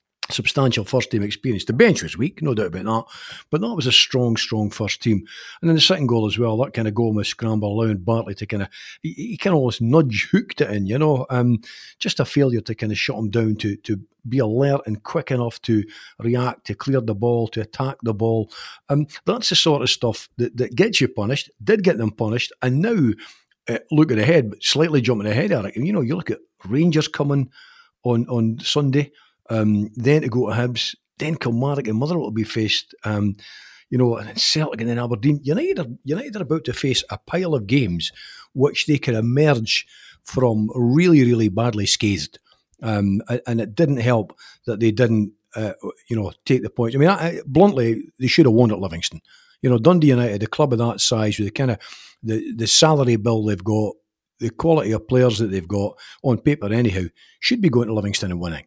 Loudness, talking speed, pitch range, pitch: -20 LUFS, 220 wpm, 110-140 Hz, 120 Hz